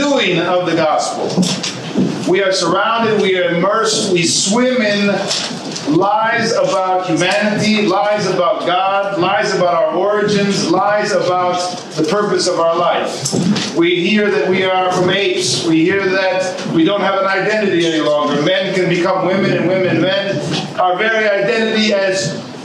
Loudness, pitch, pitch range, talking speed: -14 LUFS, 190 Hz, 180-205 Hz, 155 wpm